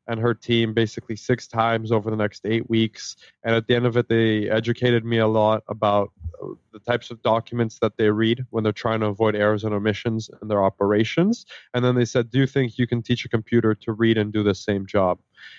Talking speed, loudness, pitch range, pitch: 230 wpm, -22 LUFS, 105-120 Hz, 115 Hz